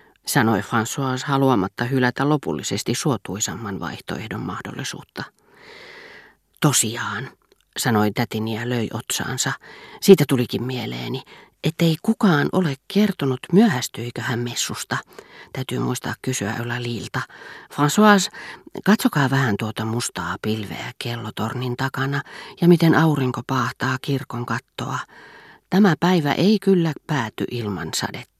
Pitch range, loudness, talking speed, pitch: 120-165 Hz, -21 LUFS, 105 wpm, 130 Hz